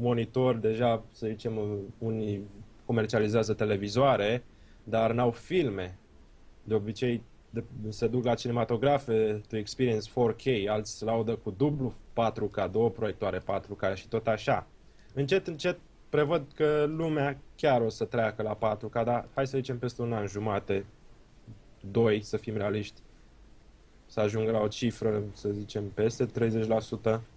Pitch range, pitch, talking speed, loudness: 105-120 Hz, 110 Hz, 140 wpm, -30 LUFS